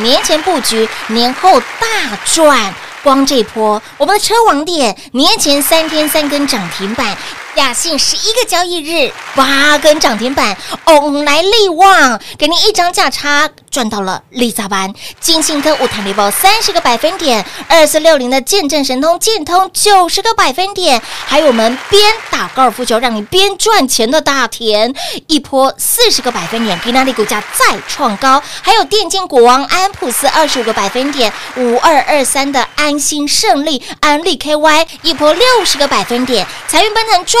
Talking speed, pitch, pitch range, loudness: 260 characters per minute, 295 Hz, 250-355 Hz, -10 LUFS